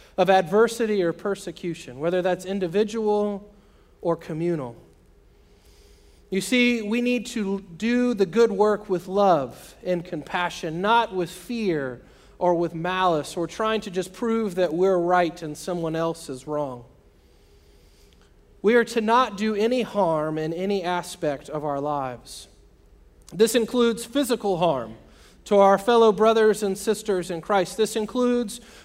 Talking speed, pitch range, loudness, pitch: 140 wpm, 155-215 Hz, -23 LUFS, 185 Hz